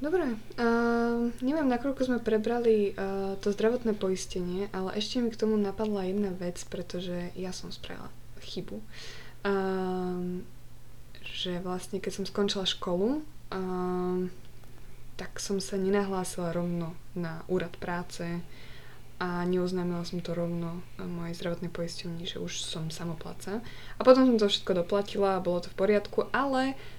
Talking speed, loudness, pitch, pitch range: 140 wpm, -30 LUFS, 185 Hz, 175-205 Hz